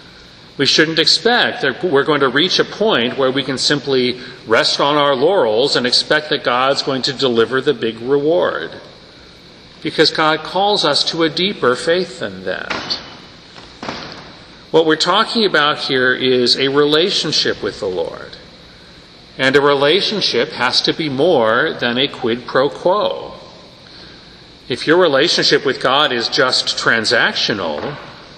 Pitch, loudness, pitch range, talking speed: 155 Hz, -15 LUFS, 140-215 Hz, 145 wpm